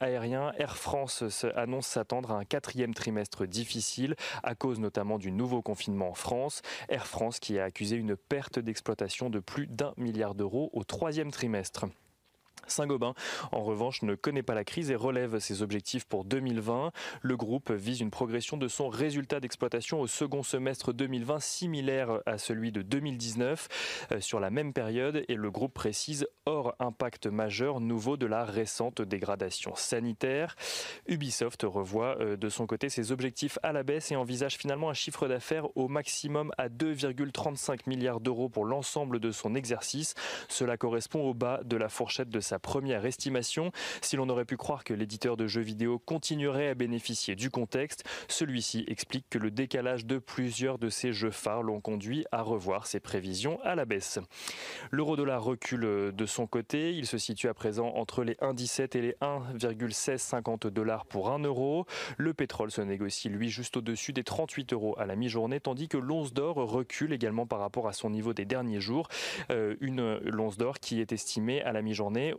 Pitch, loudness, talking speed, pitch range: 125 Hz, -33 LUFS, 180 wpm, 110-135 Hz